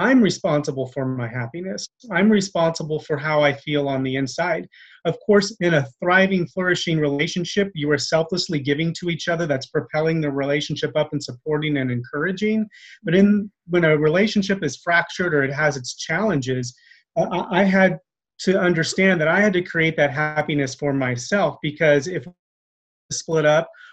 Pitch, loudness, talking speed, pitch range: 160 Hz, -21 LUFS, 170 wpm, 145-185 Hz